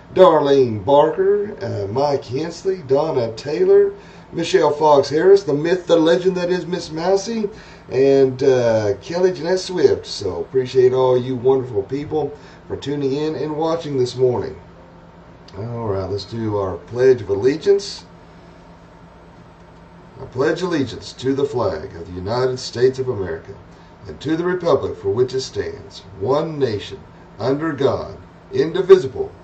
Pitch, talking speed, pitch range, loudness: 150 Hz, 140 wpm, 125-205 Hz, -18 LUFS